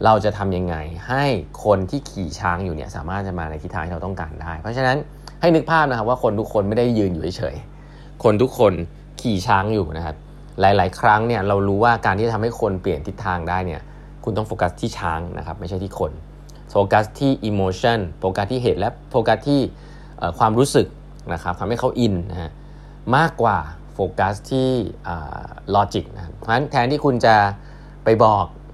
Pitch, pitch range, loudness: 105 Hz, 90-120 Hz, -20 LUFS